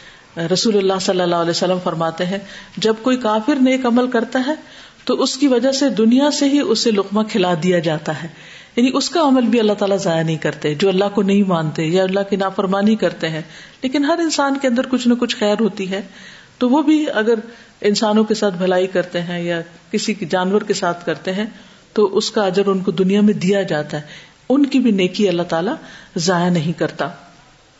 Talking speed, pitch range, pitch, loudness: 210 wpm, 175-230 Hz, 200 Hz, -17 LUFS